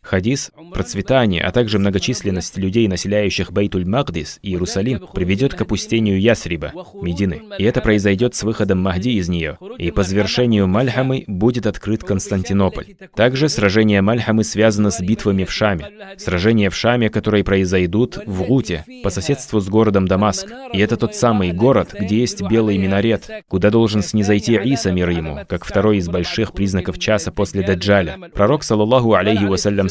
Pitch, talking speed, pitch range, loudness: 105 Hz, 155 wpm, 95-115 Hz, -17 LUFS